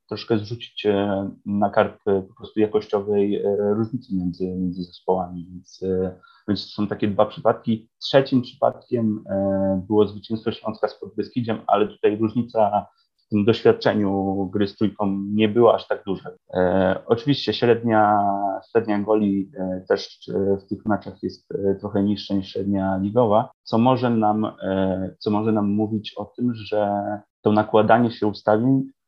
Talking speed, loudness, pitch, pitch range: 140 wpm, -22 LUFS, 105 Hz, 100-110 Hz